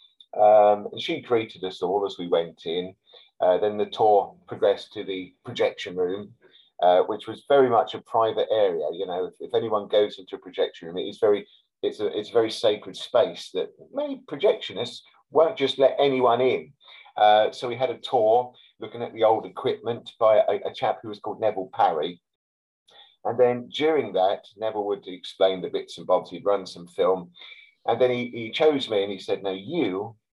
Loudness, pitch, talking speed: -24 LUFS, 125 Hz, 200 wpm